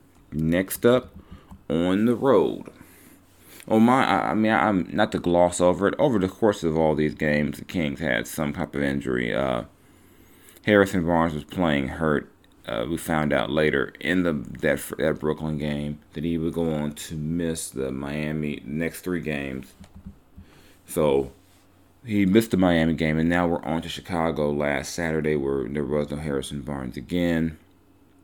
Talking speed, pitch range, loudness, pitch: 170 wpm, 75-90 Hz, -24 LUFS, 80 Hz